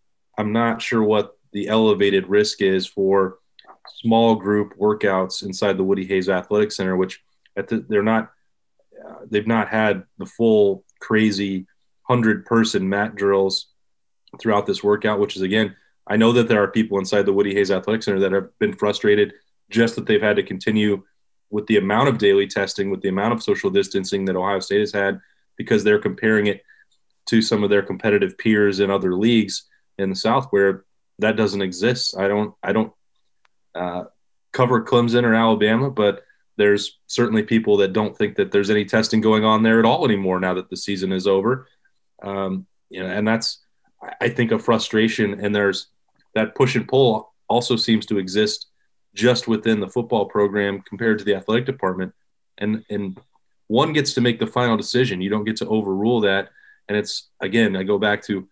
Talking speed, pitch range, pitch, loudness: 185 wpm, 100-110 Hz, 105 Hz, -20 LUFS